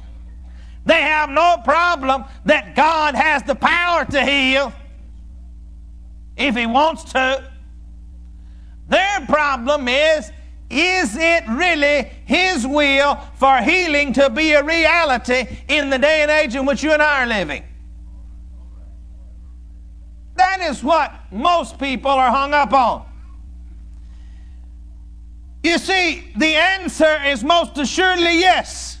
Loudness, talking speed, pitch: -16 LUFS, 120 wpm, 270 Hz